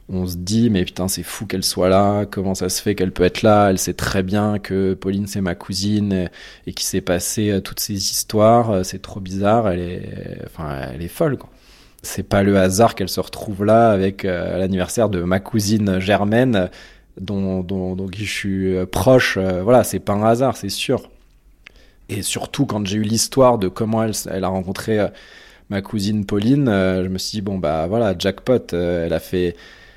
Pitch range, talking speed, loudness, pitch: 95-105 Hz, 195 wpm, -19 LUFS, 100 Hz